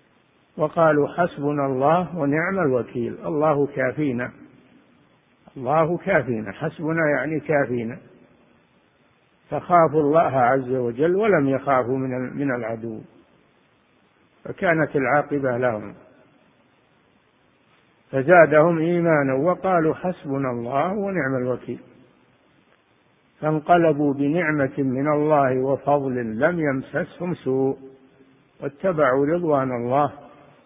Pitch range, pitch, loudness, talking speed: 130-155 Hz, 145 Hz, -21 LUFS, 80 wpm